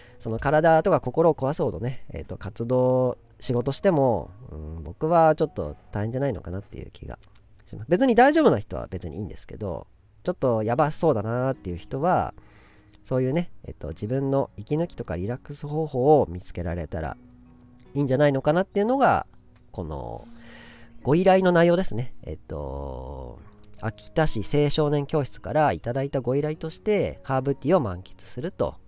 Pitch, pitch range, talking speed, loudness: 125 Hz, 100-150 Hz, 350 characters per minute, -24 LUFS